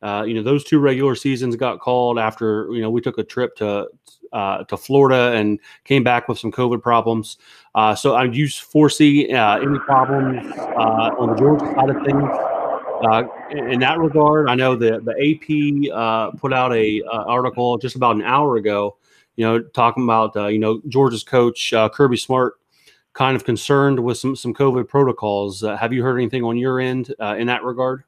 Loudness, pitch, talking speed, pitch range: -18 LUFS, 125 Hz, 200 wpm, 115-135 Hz